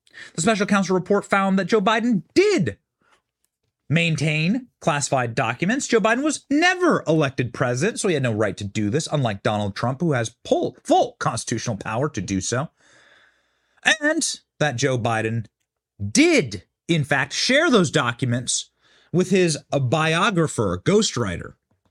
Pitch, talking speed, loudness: 155 Hz, 145 wpm, -21 LUFS